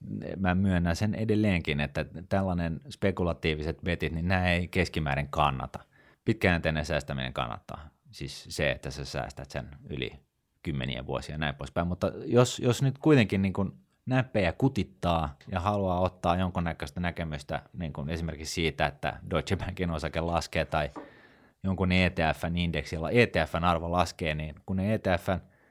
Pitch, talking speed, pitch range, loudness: 85 Hz, 140 wpm, 80-95 Hz, -29 LUFS